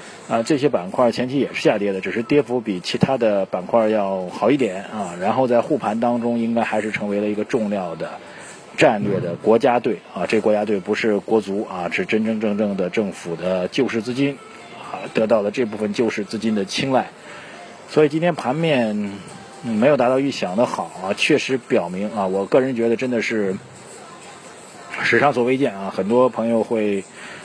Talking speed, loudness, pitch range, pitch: 285 characters per minute, -20 LUFS, 105-125 Hz, 110 Hz